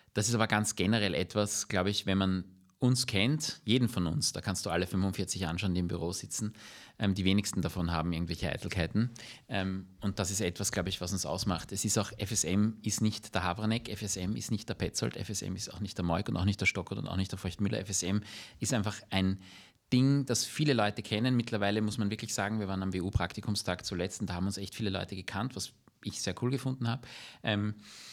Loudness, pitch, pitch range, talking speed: -32 LUFS, 100 Hz, 95-110 Hz, 225 wpm